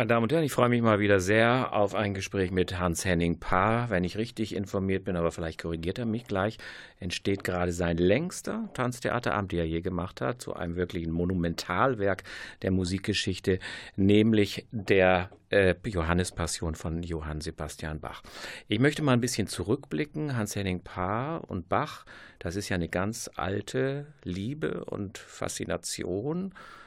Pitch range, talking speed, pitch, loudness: 90-115 Hz, 160 wpm, 95 Hz, -29 LUFS